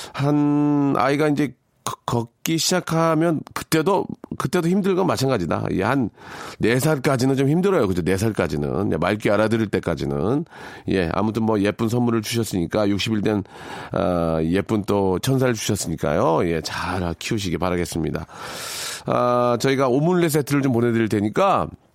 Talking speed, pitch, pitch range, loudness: 315 characters per minute, 115 Hz, 95-140 Hz, -21 LUFS